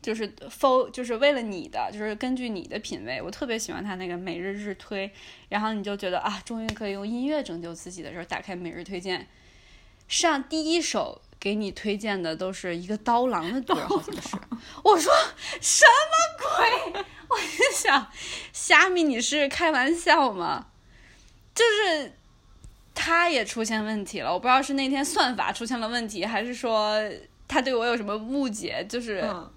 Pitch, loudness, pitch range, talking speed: 235 Hz, -25 LUFS, 200-290 Hz, 265 characters per minute